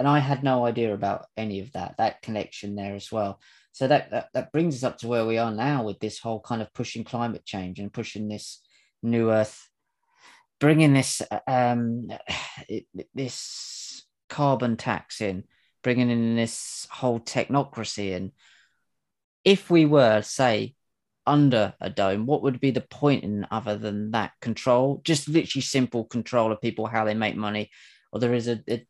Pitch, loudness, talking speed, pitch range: 115 Hz, -25 LUFS, 175 wpm, 105-135 Hz